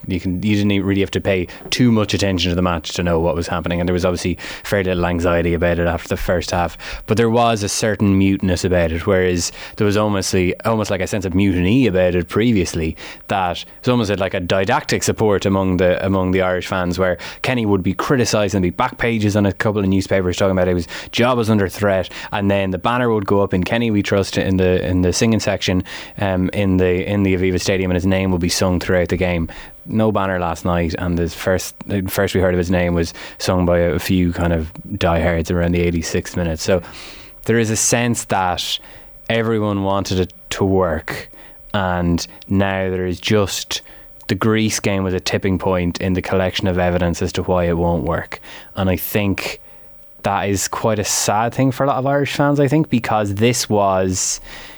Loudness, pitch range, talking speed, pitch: -18 LUFS, 90-105 Hz, 220 wpm, 95 Hz